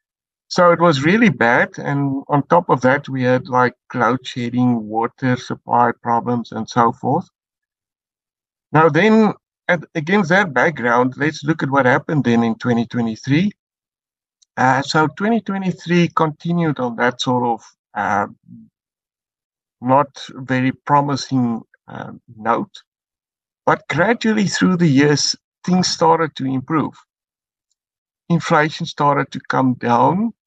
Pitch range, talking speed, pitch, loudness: 125-170 Hz, 125 wpm, 145 Hz, -17 LUFS